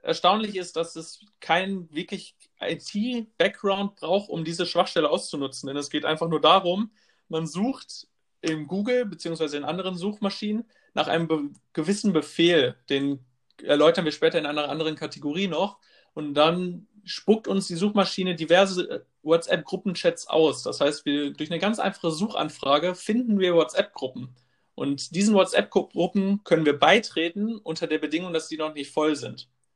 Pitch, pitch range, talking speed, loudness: 170 Hz, 155-200 Hz, 155 wpm, -25 LUFS